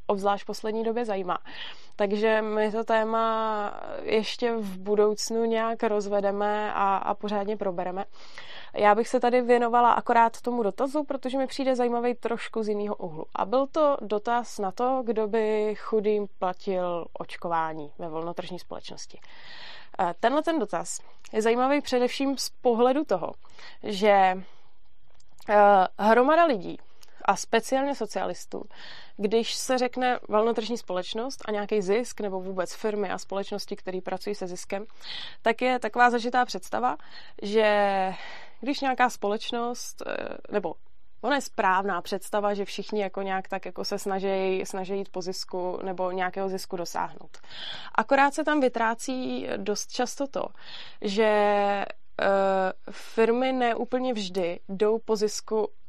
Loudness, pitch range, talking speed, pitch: -27 LUFS, 195-245 Hz, 135 wpm, 215 Hz